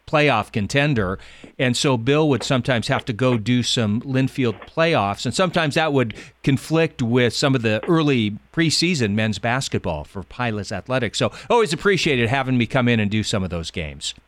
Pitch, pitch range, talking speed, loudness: 125 Hz, 110-145 Hz, 180 wpm, -20 LUFS